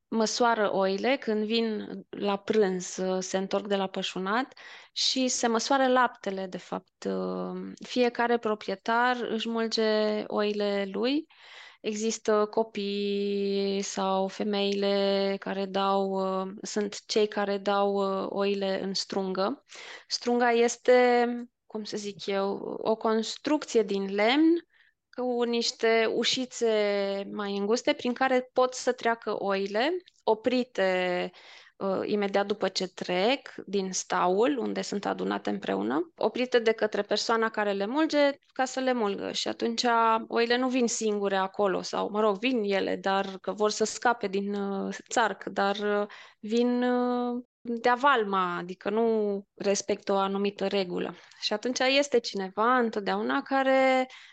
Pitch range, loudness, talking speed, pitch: 195-240 Hz, -28 LUFS, 130 wpm, 215 Hz